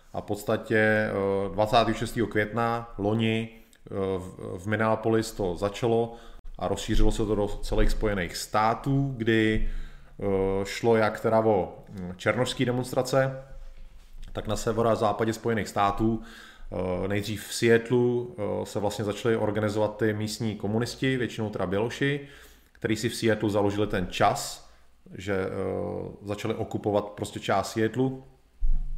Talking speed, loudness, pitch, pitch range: 120 wpm, -27 LUFS, 110 Hz, 100-115 Hz